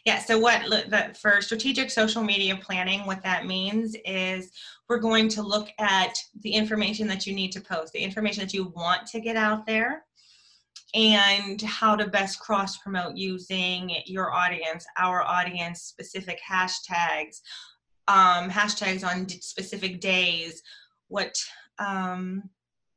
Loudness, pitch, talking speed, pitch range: -25 LUFS, 195 Hz, 135 wpm, 185-215 Hz